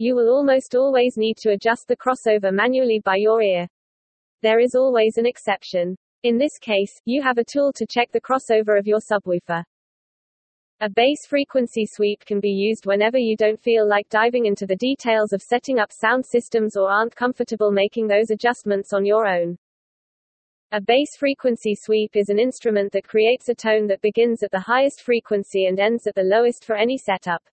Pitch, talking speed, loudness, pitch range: 220 Hz, 190 wpm, -20 LUFS, 205-245 Hz